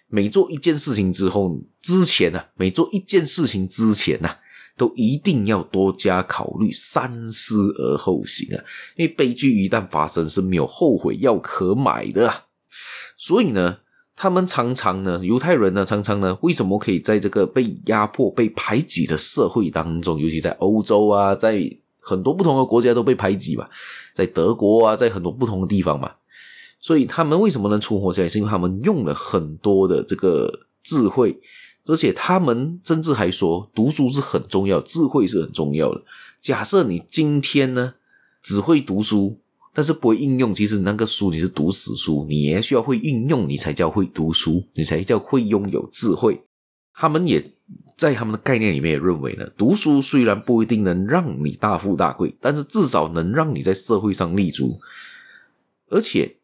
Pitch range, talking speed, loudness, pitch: 95-140 Hz, 275 characters per minute, -19 LUFS, 105 Hz